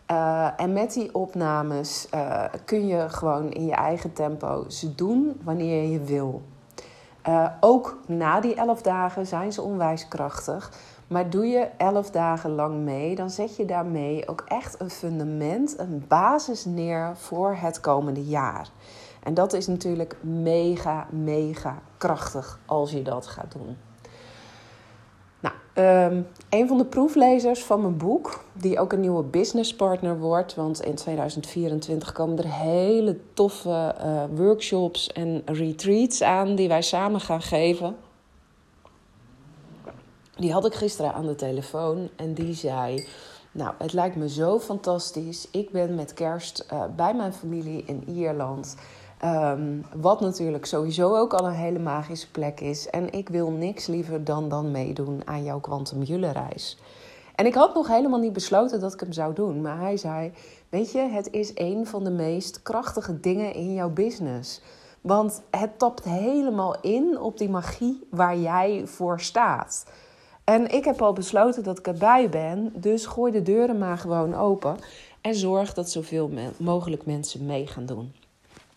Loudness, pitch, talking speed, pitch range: -25 LUFS, 170 Hz, 160 wpm, 150-200 Hz